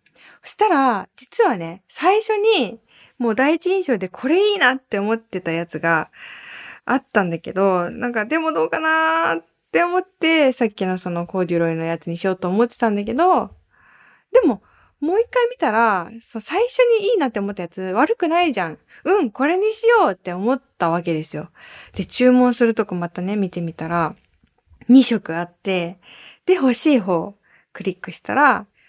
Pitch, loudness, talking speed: 225 Hz, -19 LUFS, 330 characters per minute